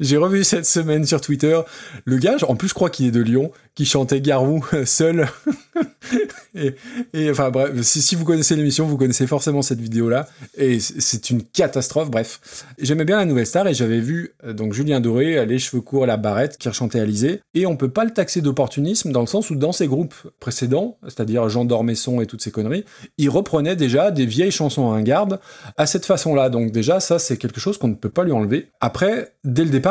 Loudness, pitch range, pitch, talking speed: -19 LUFS, 125-170 Hz, 140 Hz, 220 wpm